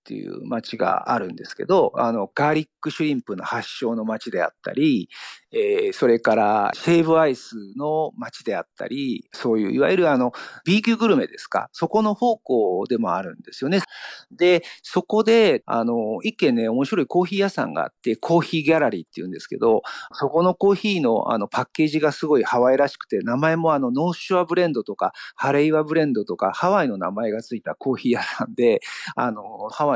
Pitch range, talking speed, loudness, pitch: 145-200 Hz, 410 characters per minute, -21 LUFS, 165 Hz